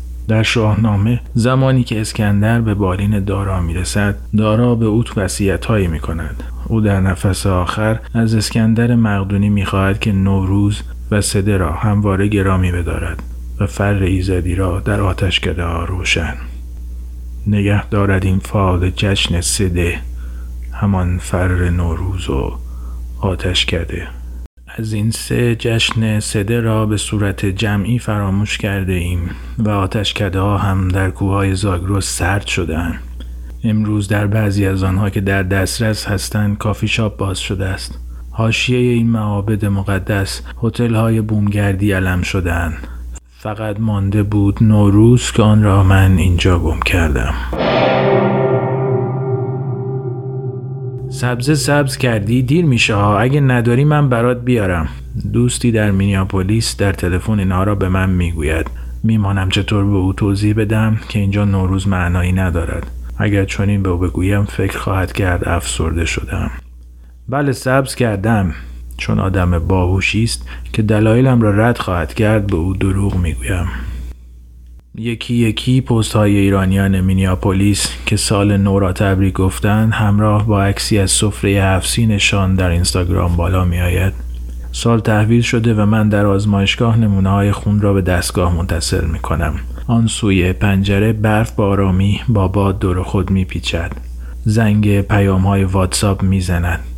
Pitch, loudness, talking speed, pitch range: 100 Hz, -15 LUFS, 140 wpm, 90-110 Hz